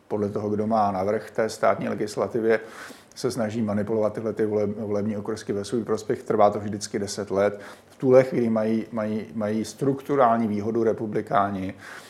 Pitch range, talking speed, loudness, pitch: 105-110 Hz, 165 wpm, -25 LUFS, 110 Hz